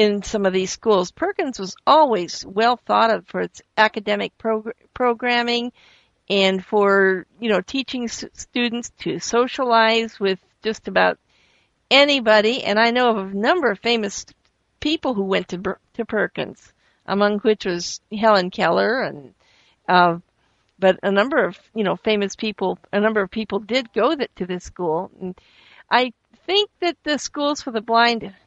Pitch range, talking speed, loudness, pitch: 195-240 Hz, 160 wpm, -20 LUFS, 215 Hz